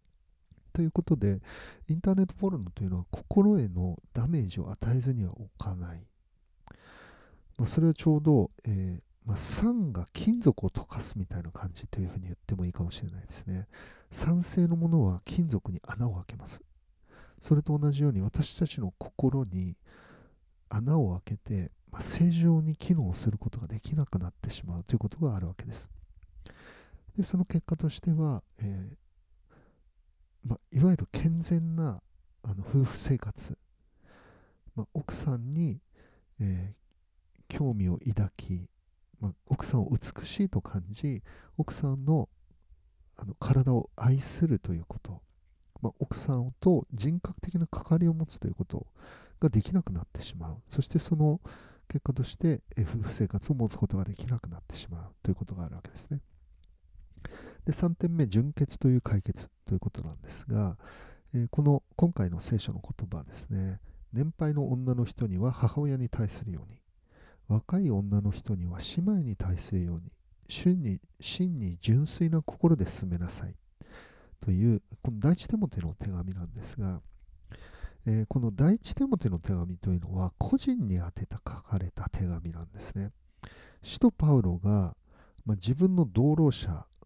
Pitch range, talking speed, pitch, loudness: 90-145 Hz, 310 characters per minute, 105 Hz, -30 LUFS